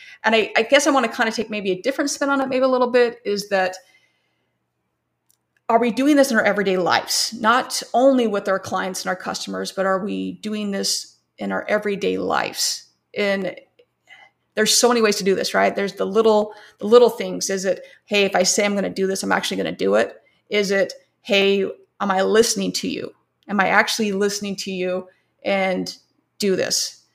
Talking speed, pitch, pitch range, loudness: 210 wpm, 205 Hz, 185-230 Hz, -20 LUFS